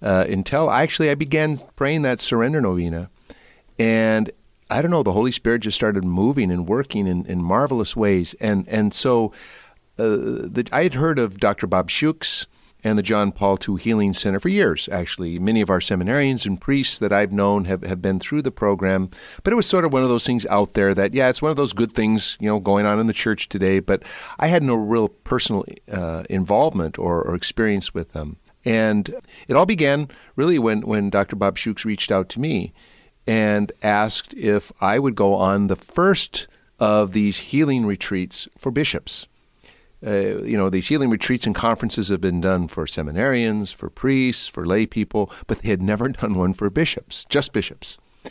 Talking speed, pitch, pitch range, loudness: 200 wpm, 105 Hz, 95-120 Hz, -20 LUFS